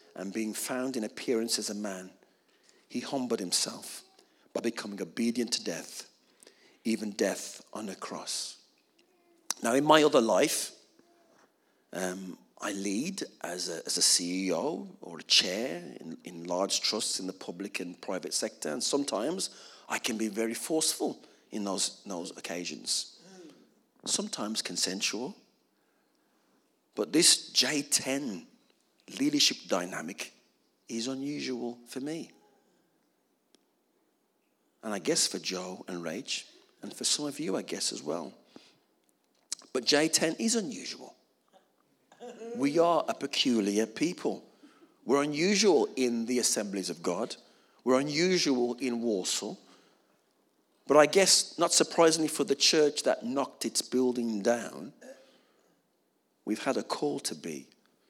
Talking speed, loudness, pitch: 130 wpm, -29 LUFS, 135 Hz